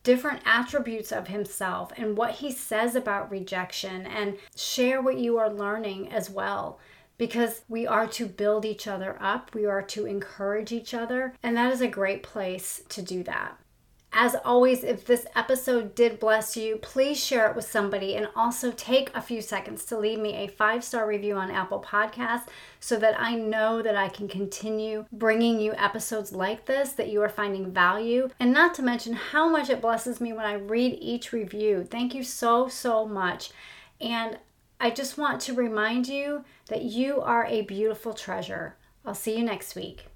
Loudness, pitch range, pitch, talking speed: -27 LUFS, 210-240 Hz, 220 Hz, 185 wpm